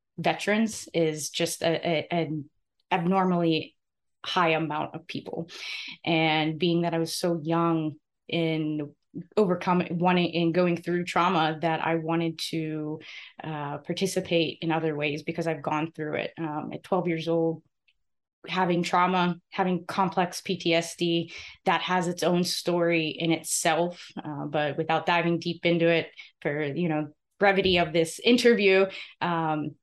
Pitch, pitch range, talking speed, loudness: 165 Hz, 160-175 Hz, 145 wpm, -26 LUFS